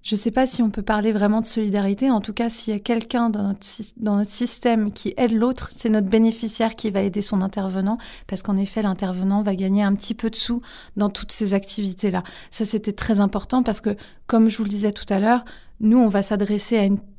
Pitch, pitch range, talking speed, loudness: 215 Hz, 200-230 Hz, 240 wpm, -22 LUFS